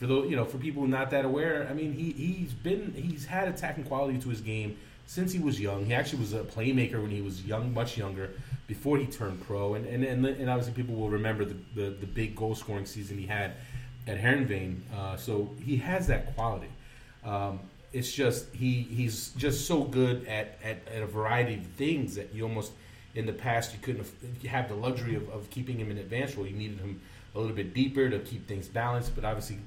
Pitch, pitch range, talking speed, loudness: 120 Hz, 105-130 Hz, 230 wpm, -32 LUFS